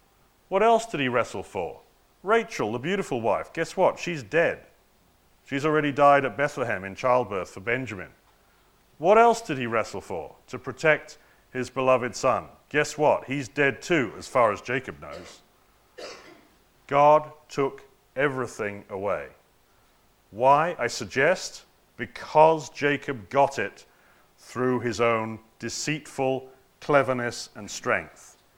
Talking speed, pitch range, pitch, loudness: 130 wpm, 125-155 Hz, 140 Hz, -25 LUFS